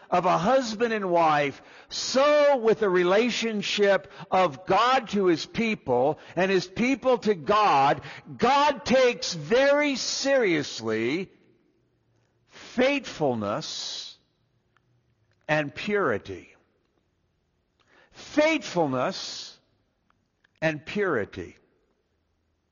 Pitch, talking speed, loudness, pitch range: 195 Hz, 75 wpm, -24 LUFS, 150-250 Hz